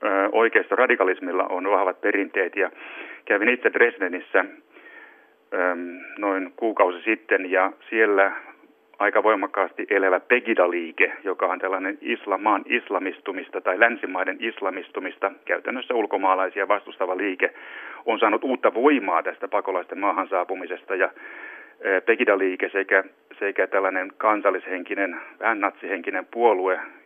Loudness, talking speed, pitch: -23 LUFS, 105 wpm, 340 Hz